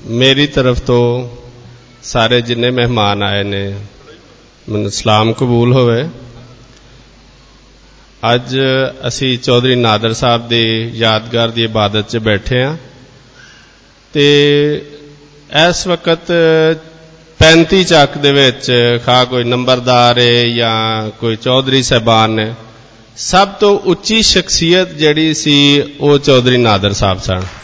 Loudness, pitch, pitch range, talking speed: -11 LUFS, 125 Hz, 115-145 Hz, 110 wpm